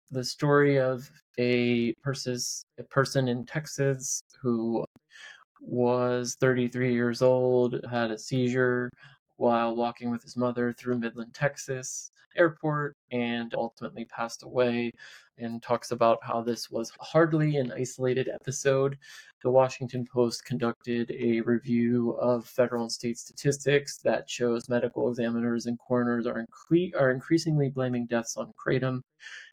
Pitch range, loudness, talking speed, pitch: 120-135 Hz, -28 LUFS, 130 wpm, 125 Hz